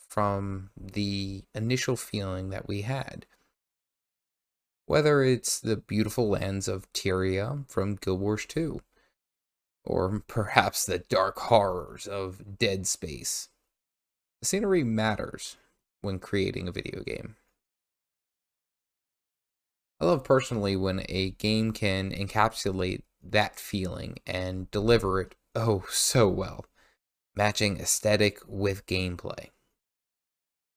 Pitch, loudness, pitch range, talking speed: 100 Hz, -28 LUFS, 95-110 Hz, 105 wpm